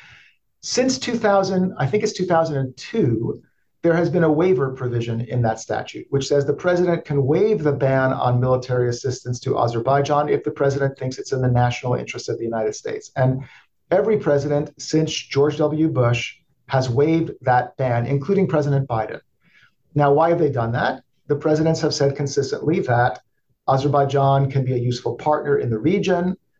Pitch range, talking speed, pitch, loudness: 130-160 Hz, 170 wpm, 140 Hz, -20 LUFS